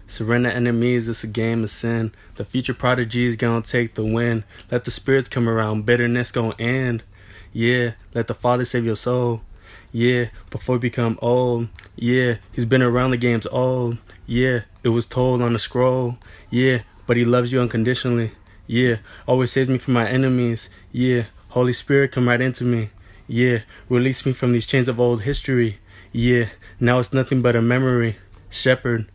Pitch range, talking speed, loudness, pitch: 110-125 Hz, 175 wpm, -20 LUFS, 120 Hz